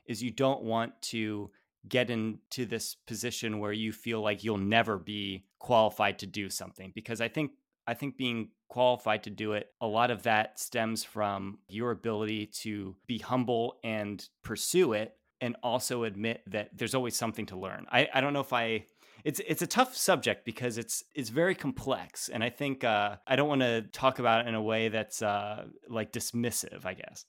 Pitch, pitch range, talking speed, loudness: 115 Hz, 105-125 Hz, 195 wpm, -32 LUFS